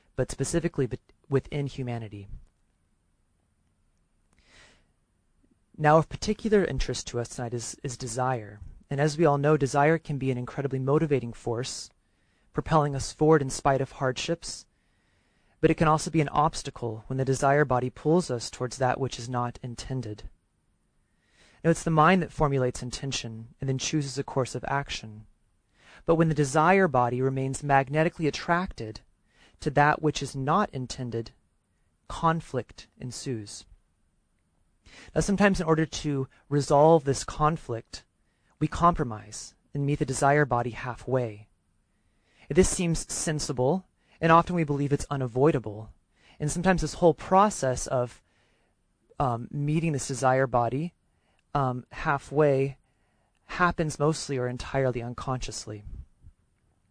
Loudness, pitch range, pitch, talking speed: -27 LUFS, 110-150 Hz, 130 Hz, 130 wpm